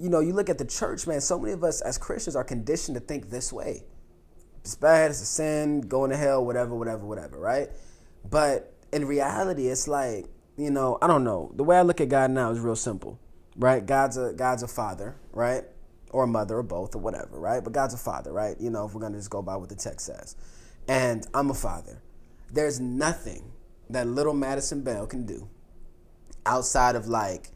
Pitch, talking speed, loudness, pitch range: 125 Hz, 215 wpm, -27 LUFS, 115-145 Hz